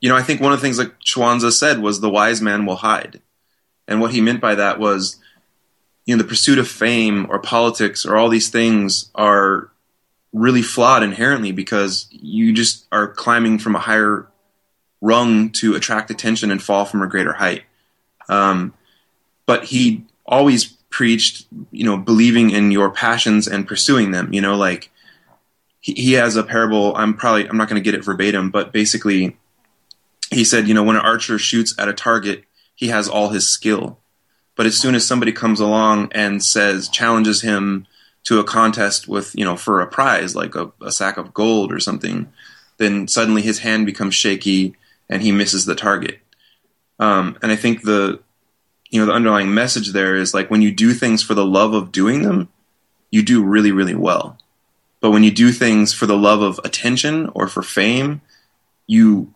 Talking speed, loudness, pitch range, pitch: 190 wpm, -16 LUFS, 100-115 Hz, 110 Hz